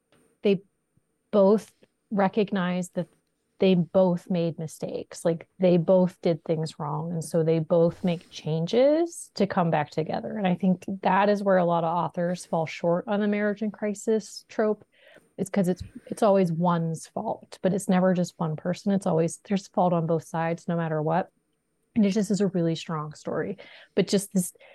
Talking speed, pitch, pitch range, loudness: 185 wpm, 180 Hz, 170-200 Hz, -26 LUFS